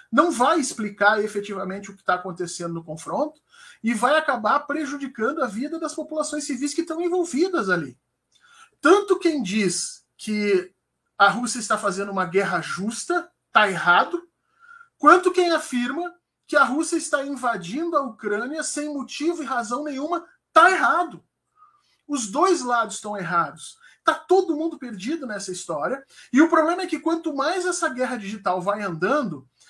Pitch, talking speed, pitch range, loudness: 285 Hz, 155 wpm, 210-330 Hz, -23 LUFS